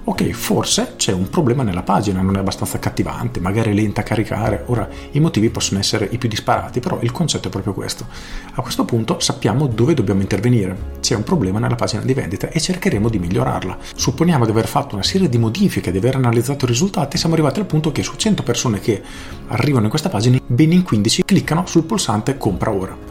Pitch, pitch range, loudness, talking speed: 120 Hz, 100-150 Hz, -18 LUFS, 215 wpm